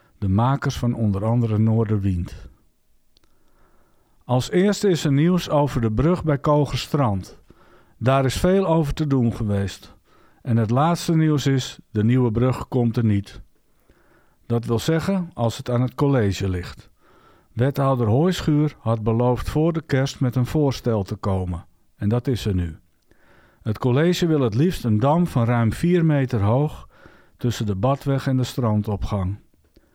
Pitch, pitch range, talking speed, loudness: 125 Hz, 110-145 Hz, 155 wpm, -21 LUFS